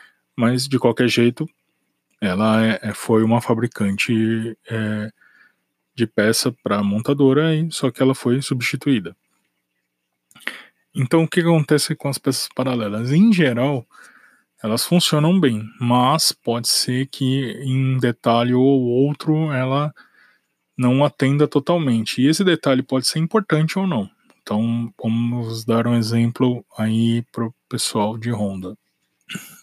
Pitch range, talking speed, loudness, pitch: 115-140 Hz, 130 wpm, -19 LUFS, 125 Hz